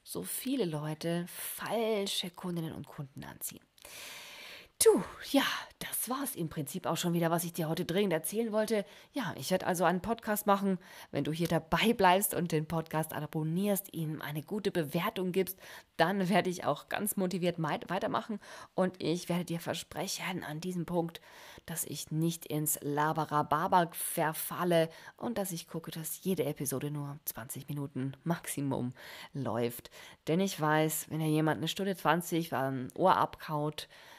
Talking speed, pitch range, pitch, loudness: 160 wpm, 150-185 Hz, 165 Hz, -33 LUFS